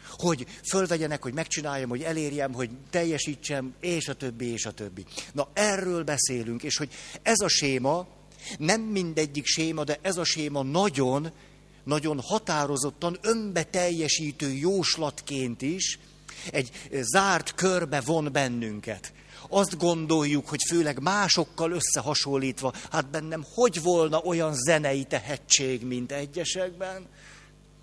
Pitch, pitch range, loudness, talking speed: 155 Hz, 140-175 Hz, -27 LUFS, 120 wpm